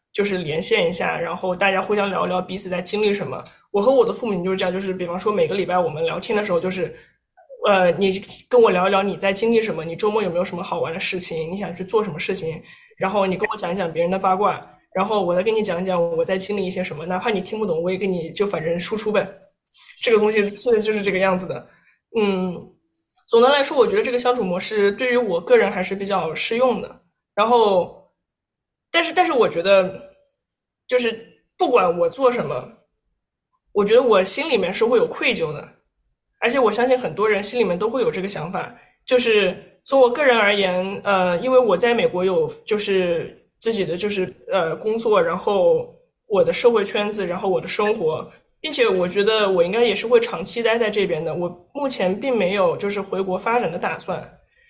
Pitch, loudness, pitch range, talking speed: 205 Hz, -19 LUFS, 185-245 Hz, 320 characters per minute